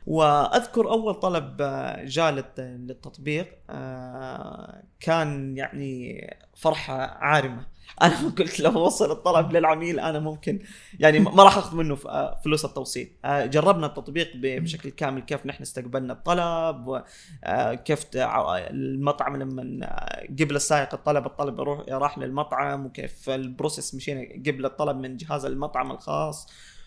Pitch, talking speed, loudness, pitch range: 145 Hz, 115 wpm, -25 LUFS, 135-165 Hz